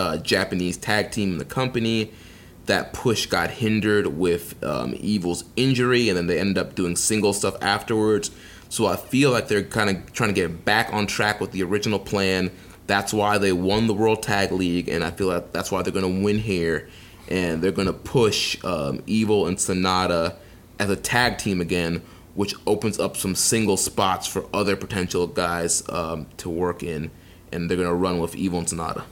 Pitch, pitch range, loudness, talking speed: 95 Hz, 90-105 Hz, -23 LUFS, 200 wpm